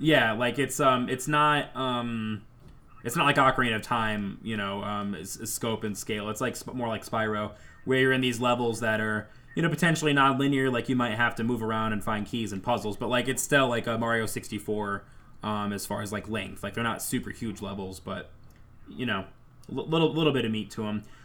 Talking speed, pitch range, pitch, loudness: 230 wpm, 105-130 Hz, 115 Hz, -28 LUFS